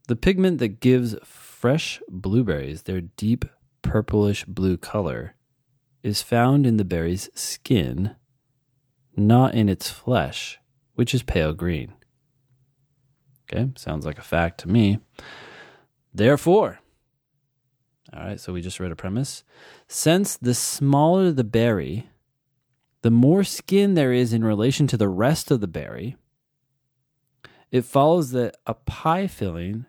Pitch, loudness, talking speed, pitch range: 125 Hz, -22 LUFS, 130 wpm, 105-140 Hz